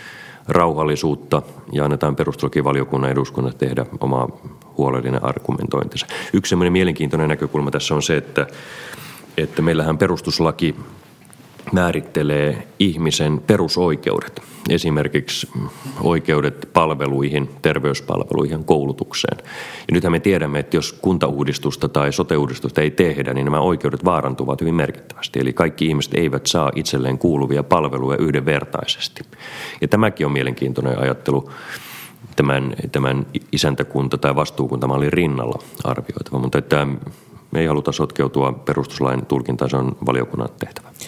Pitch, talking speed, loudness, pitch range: 70 Hz, 110 wpm, -19 LUFS, 65-80 Hz